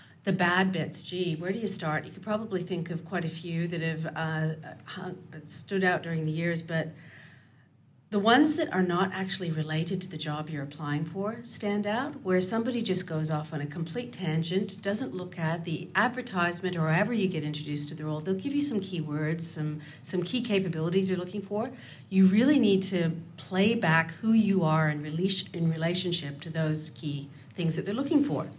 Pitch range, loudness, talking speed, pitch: 155-195 Hz, -29 LUFS, 200 wpm, 170 Hz